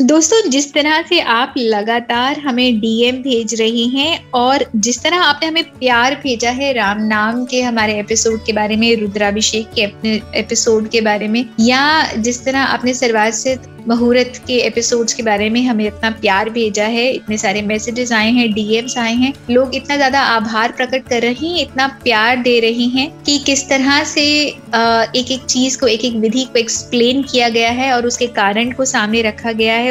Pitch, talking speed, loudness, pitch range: 240 Hz, 190 wpm, -14 LUFS, 225-265 Hz